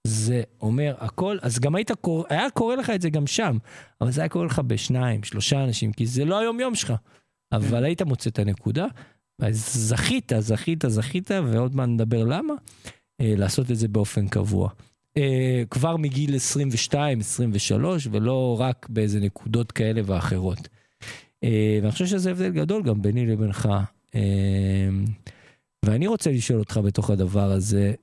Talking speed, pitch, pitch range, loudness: 150 wpm, 120 Hz, 110-145 Hz, -24 LUFS